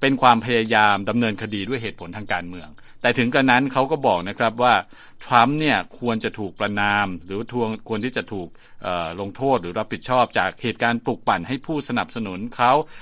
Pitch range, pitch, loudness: 100-125 Hz, 115 Hz, -21 LUFS